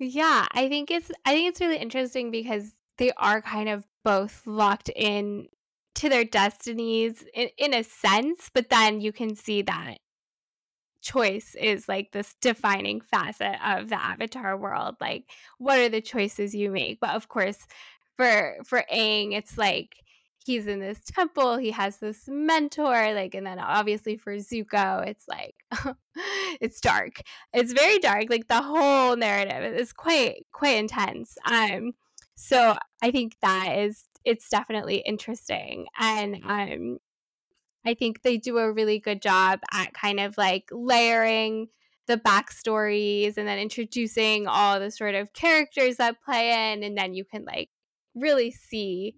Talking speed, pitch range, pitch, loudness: 155 wpm, 205-250 Hz, 220 Hz, -25 LUFS